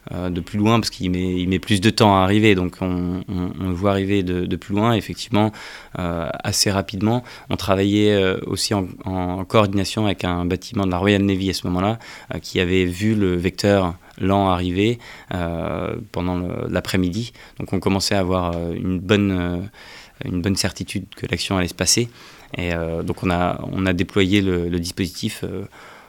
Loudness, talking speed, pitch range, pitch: -21 LUFS, 200 wpm, 90-105 Hz, 95 Hz